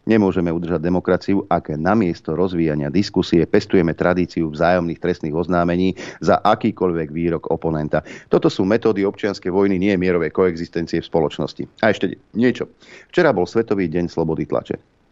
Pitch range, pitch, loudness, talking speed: 85-95 Hz, 90 Hz, -19 LUFS, 145 wpm